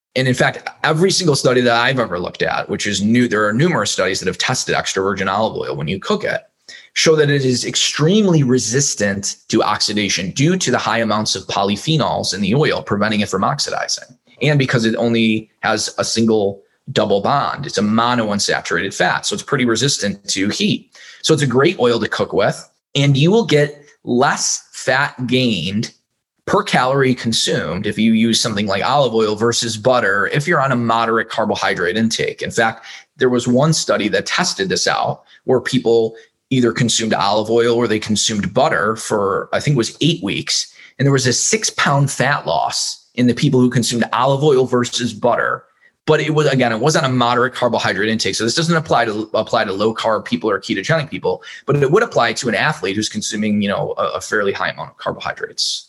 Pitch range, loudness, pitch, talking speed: 110-140 Hz, -16 LUFS, 120 Hz, 205 wpm